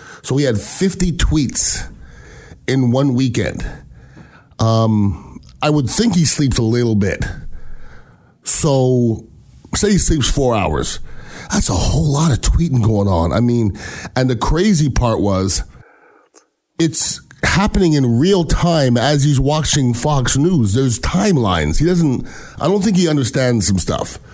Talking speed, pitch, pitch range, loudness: 145 wpm, 130 Hz, 105-155 Hz, -15 LUFS